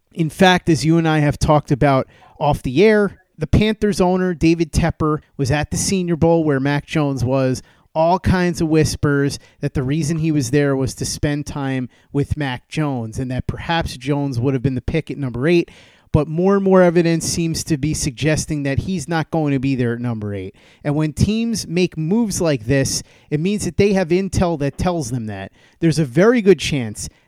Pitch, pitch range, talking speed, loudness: 150 Hz, 135-170 Hz, 210 wpm, -18 LUFS